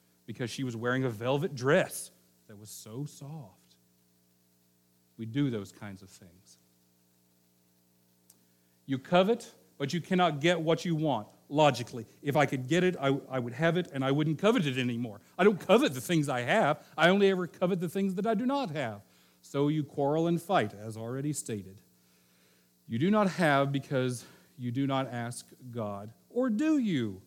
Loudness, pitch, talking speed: -30 LUFS, 130 Hz, 180 wpm